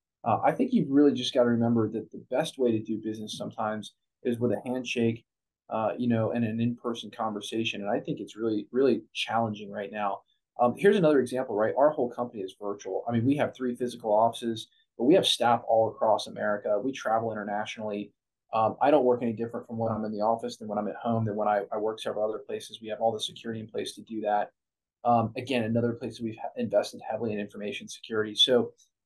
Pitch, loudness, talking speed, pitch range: 115 Hz, -28 LUFS, 230 wpm, 110-120 Hz